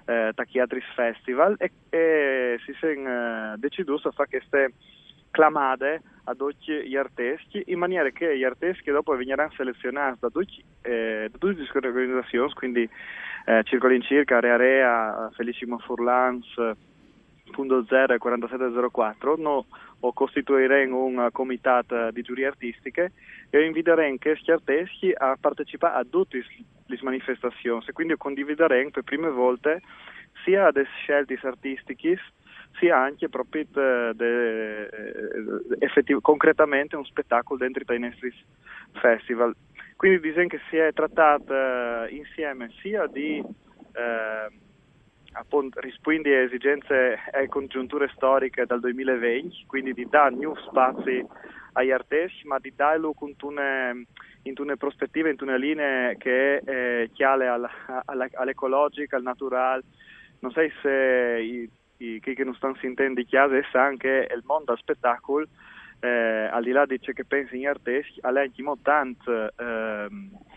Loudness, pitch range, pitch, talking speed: -25 LUFS, 125-145 Hz, 130 Hz, 130 wpm